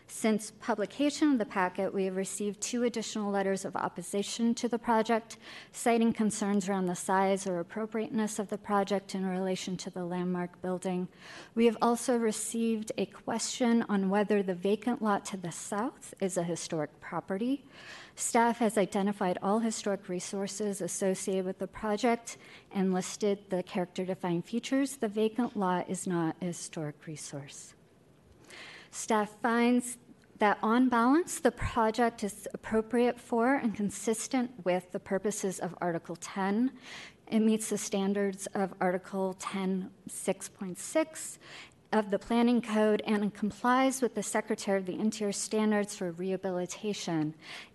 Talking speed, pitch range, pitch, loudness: 145 wpm, 190-225 Hz, 205 Hz, -31 LUFS